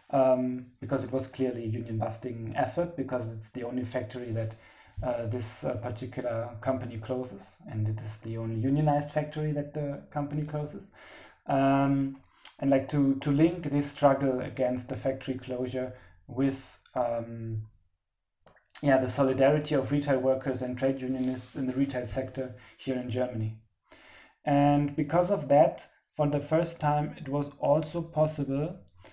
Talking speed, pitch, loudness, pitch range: 150 wpm, 130 Hz, -30 LUFS, 120-145 Hz